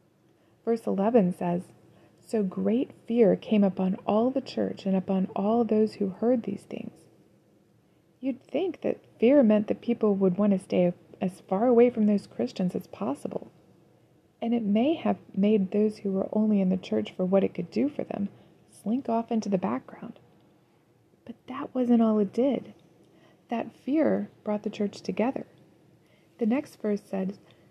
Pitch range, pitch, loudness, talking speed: 190-235 Hz, 210 Hz, -27 LUFS, 170 wpm